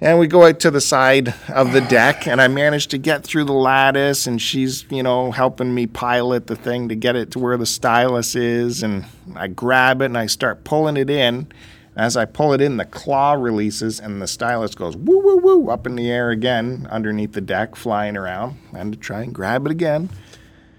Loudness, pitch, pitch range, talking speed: -17 LUFS, 125 Hz, 115-140 Hz, 220 wpm